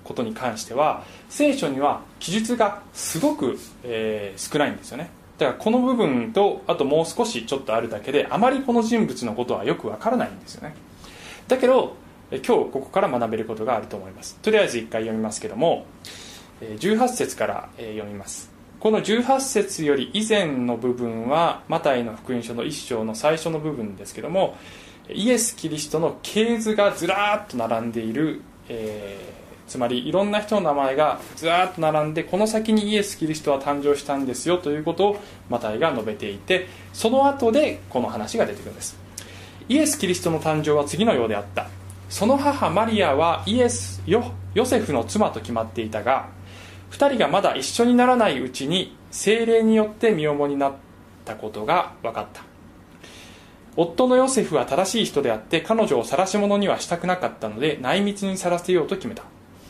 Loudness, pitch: -22 LUFS, 155 Hz